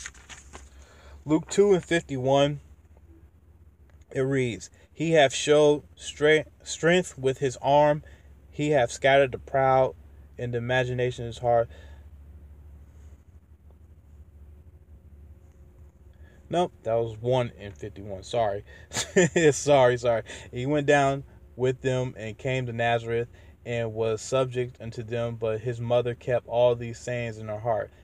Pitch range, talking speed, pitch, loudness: 80-130 Hz, 120 wpm, 115 Hz, -25 LUFS